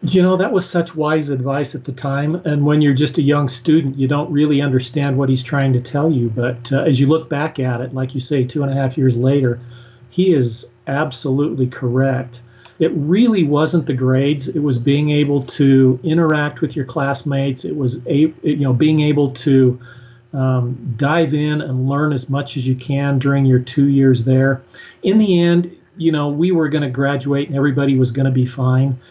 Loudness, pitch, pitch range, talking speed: -17 LUFS, 140 Hz, 130-150 Hz, 210 wpm